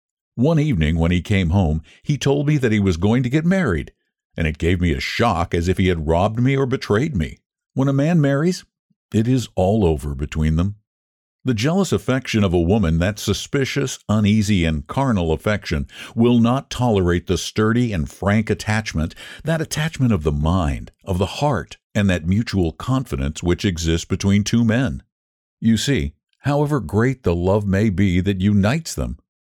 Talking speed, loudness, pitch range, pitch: 180 wpm, -20 LUFS, 85-125 Hz, 105 Hz